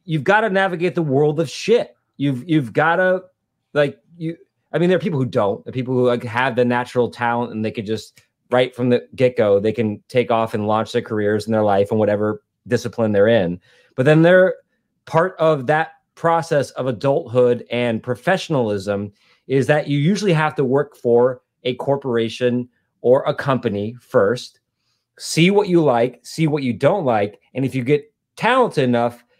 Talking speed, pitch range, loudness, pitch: 190 wpm, 120-160 Hz, -19 LUFS, 125 Hz